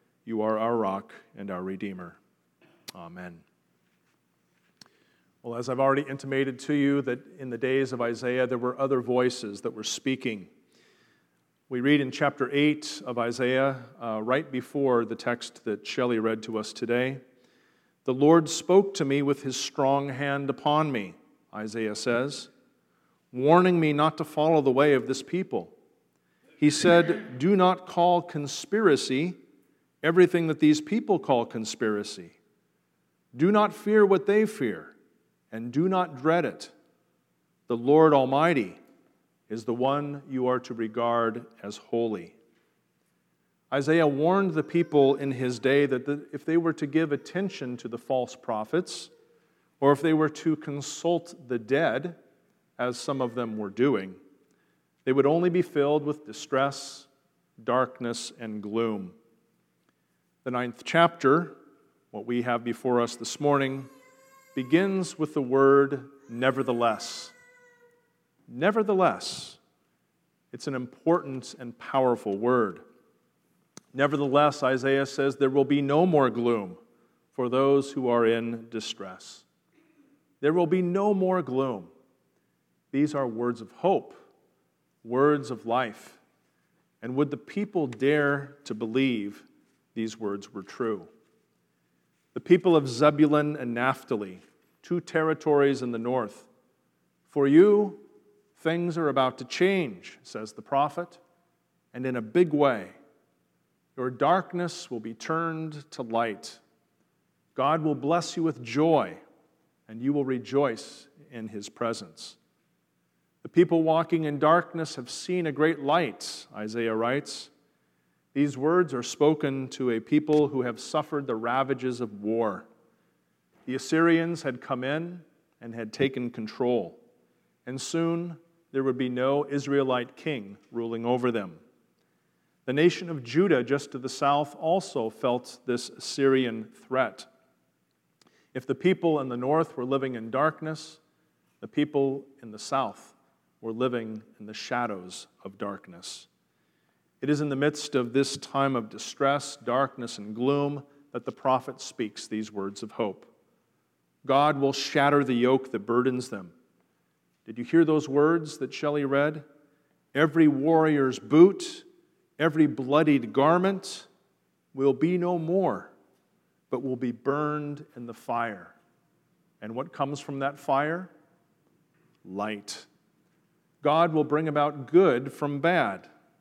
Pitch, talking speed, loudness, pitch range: 140 Hz, 135 wpm, -26 LUFS, 120-160 Hz